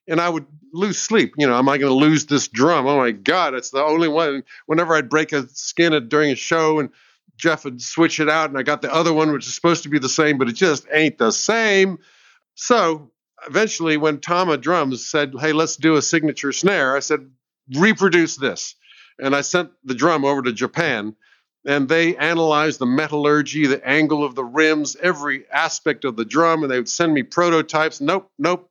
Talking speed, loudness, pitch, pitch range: 210 wpm, -18 LUFS, 155 Hz, 140-165 Hz